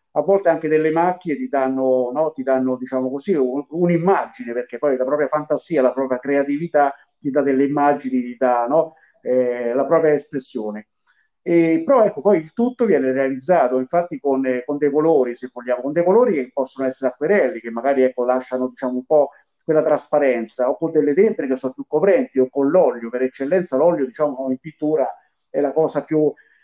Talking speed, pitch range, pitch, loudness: 190 wpm, 130-155 Hz, 140 Hz, -19 LUFS